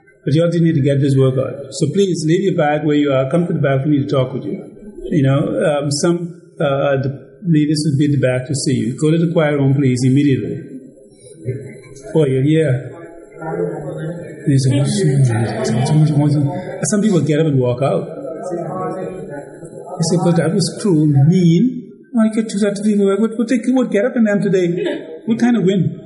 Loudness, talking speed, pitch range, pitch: -16 LUFS, 200 wpm, 135-180 Hz, 155 Hz